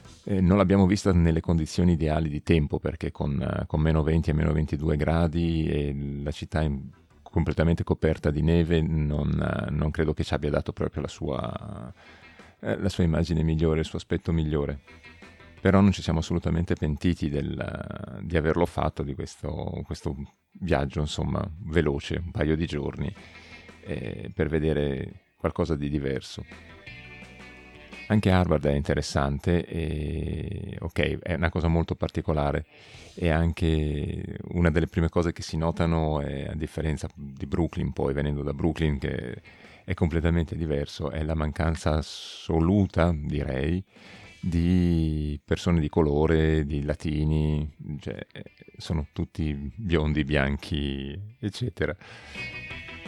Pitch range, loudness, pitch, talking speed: 75-85 Hz, -27 LUFS, 80 Hz, 135 wpm